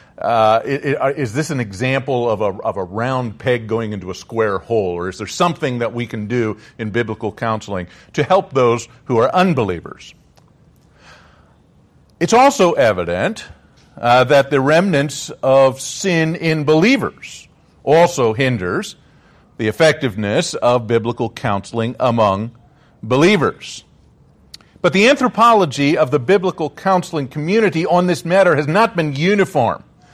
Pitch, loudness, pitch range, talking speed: 135 Hz, -16 LUFS, 115-160 Hz, 135 wpm